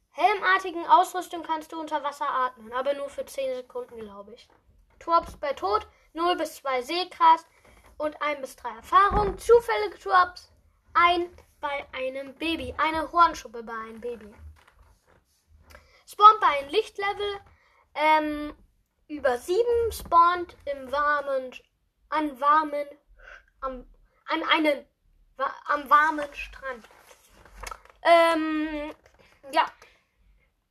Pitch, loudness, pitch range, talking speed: 300 Hz, -24 LUFS, 265-350 Hz, 110 wpm